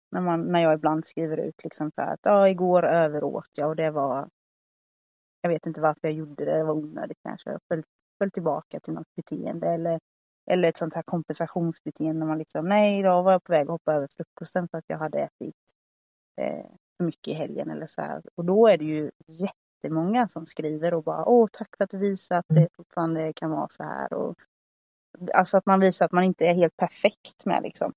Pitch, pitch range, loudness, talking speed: 165 Hz, 155-180 Hz, -25 LUFS, 220 wpm